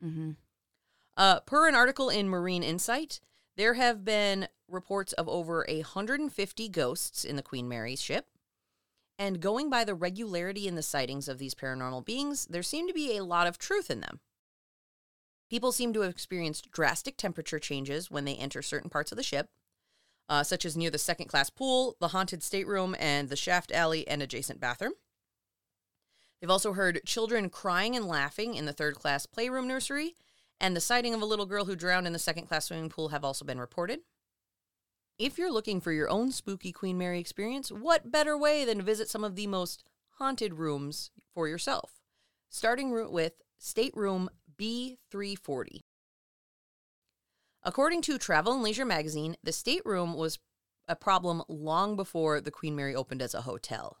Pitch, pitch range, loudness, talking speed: 185 Hz, 155-225 Hz, -31 LUFS, 175 wpm